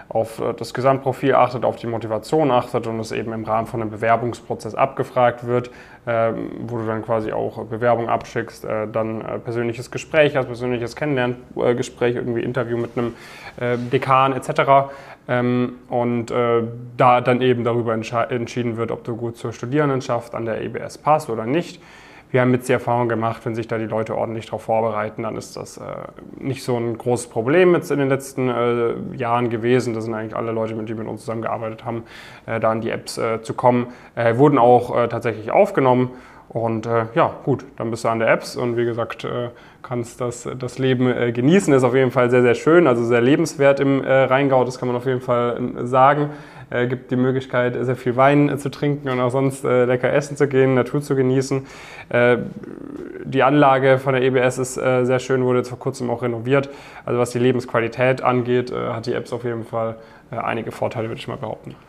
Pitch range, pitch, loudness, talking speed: 115-130 Hz, 125 Hz, -20 LUFS, 200 wpm